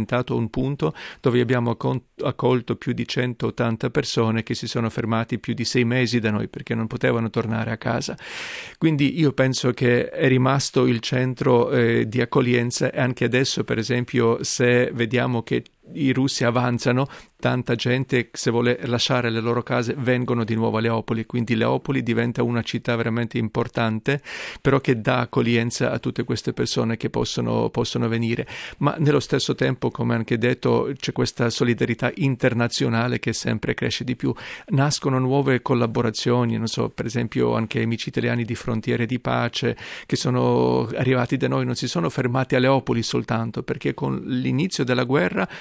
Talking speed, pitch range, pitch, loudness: 165 wpm, 115-130 Hz, 120 Hz, -22 LUFS